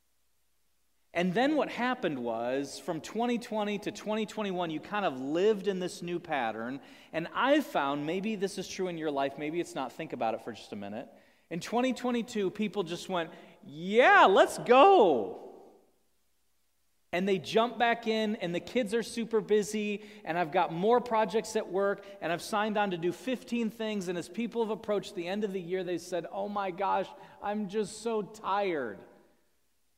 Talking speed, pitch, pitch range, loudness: 180 wpm, 200 Hz, 175-220 Hz, -30 LUFS